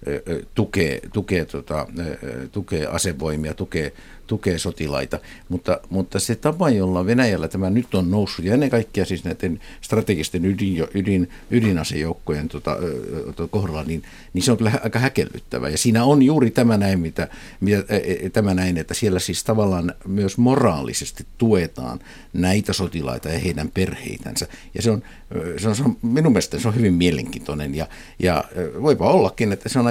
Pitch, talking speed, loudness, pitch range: 95 Hz, 155 wpm, -21 LUFS, 85-110 Hz